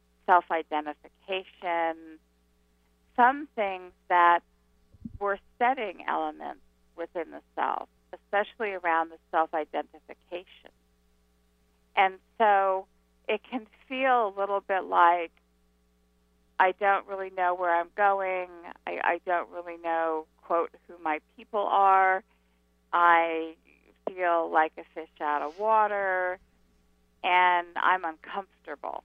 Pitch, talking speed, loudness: 170 Hz, 110 wpm, -27 LUFS